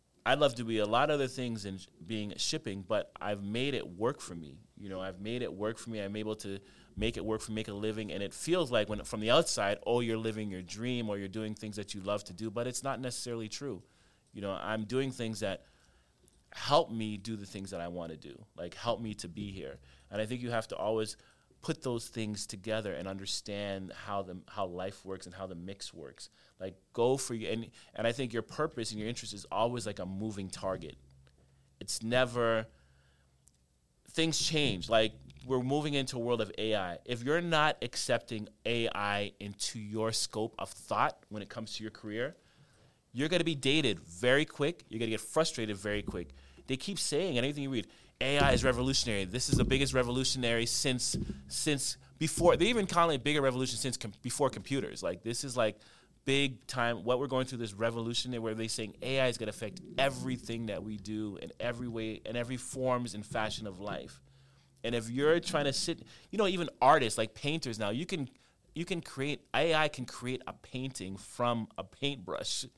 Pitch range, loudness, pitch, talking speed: 100-130 Hz, -34 LUFS, 115 Hz, 210 wpm